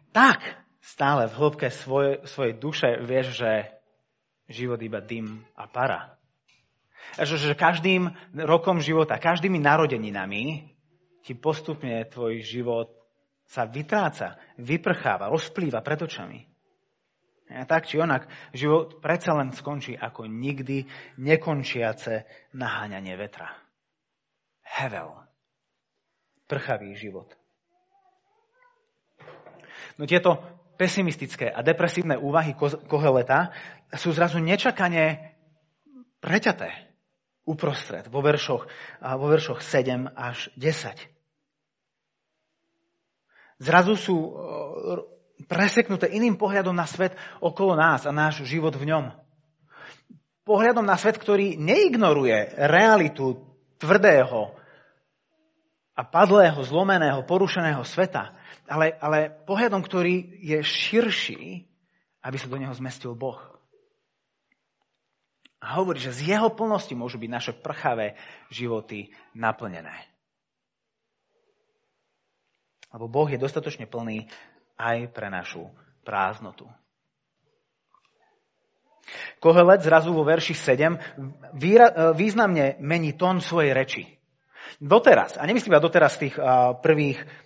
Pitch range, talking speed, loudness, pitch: 130-180 Hz, 100 wpm, -23 LUFS, 155 Hz